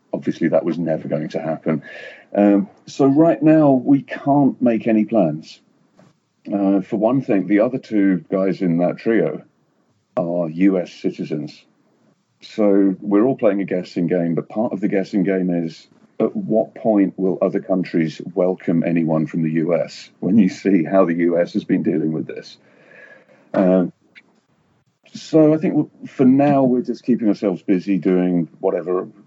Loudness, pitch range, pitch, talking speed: -18 LUFS, 85-110 Hz, 95 Hz, 160 wpm